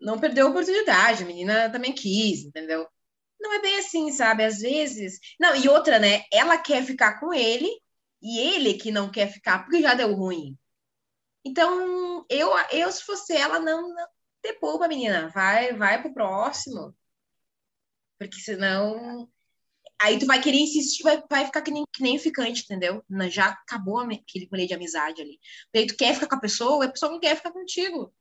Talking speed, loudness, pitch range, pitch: 185 wpm, -23 LUFS, 205-315 Hz, 245 Hz